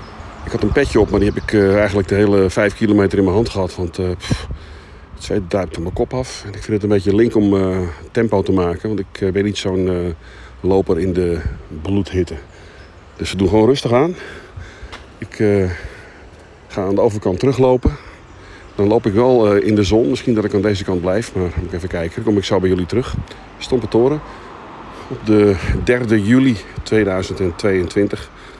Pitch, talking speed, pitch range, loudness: 100 Hz, 205 wpm, 90-105 Hz, -17 LUFS